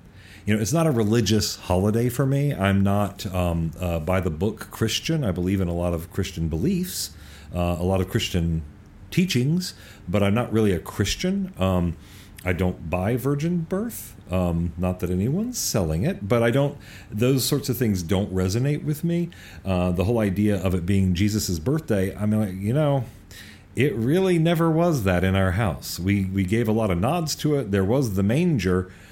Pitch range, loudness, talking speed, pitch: 95-130 Hz, -23 LUFS, 190 wpm, 100 Hz